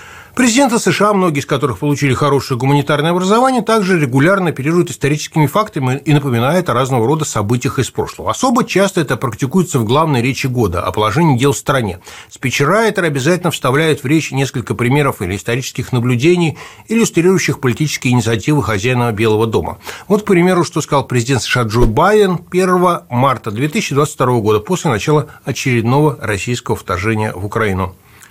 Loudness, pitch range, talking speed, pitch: -14 LUFS, 120-170 Hz, 150 wpm, 140 Hz